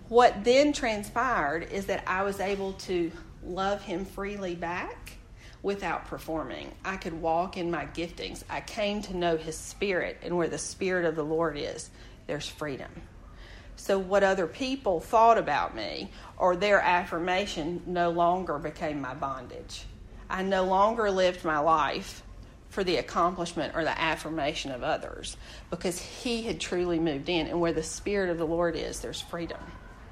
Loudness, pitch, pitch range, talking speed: -29 LUFS, 175 Hz, 160-195 Hz, 165 wpm